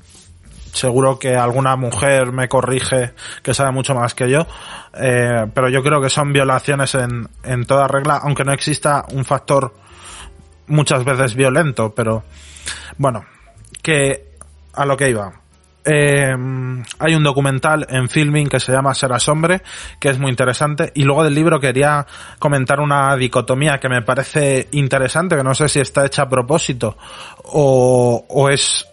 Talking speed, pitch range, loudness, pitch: 160 wpm, 125-140 Hz, -16 LUFS, 135 Hz